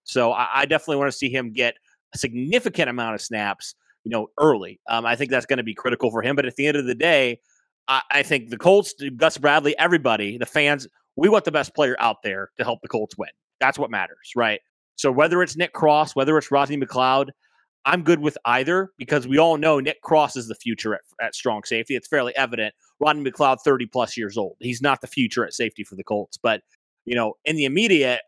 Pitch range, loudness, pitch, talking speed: 120-150 Hz, -21 LUFS, 135 Hz, 230 wpm